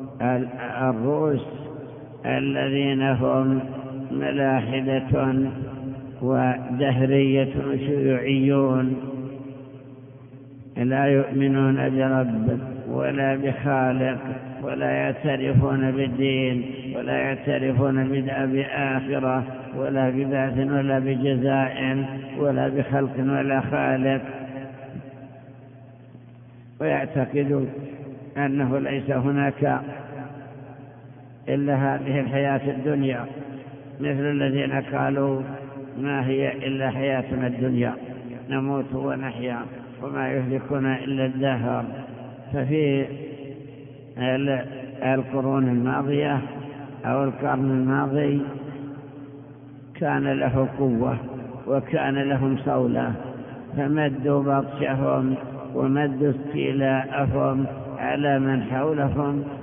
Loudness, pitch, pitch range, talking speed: -24 LUFS, 135 Hz, 130-140 Hz, 65 wpm